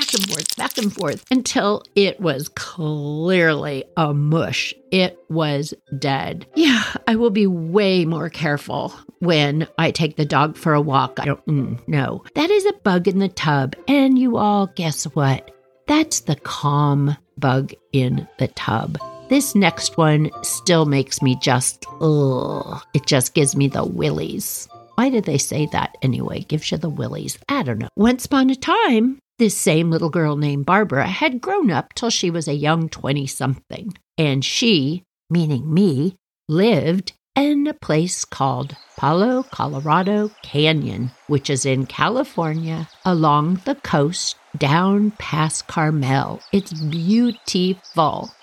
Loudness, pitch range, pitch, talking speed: -19 LUFS, 145-200 Hz, 160 Hz, 150 wpm